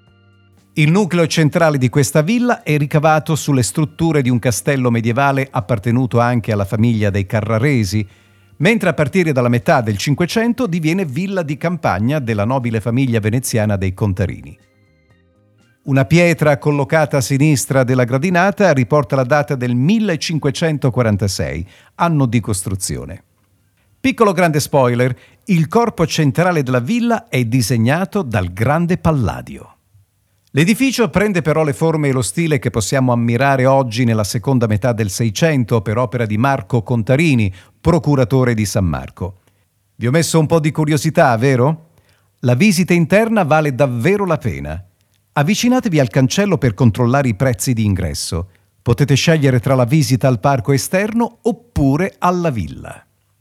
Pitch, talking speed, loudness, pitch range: 130 Hz, 140 wpm, -15 LUFS, 115-160 Hz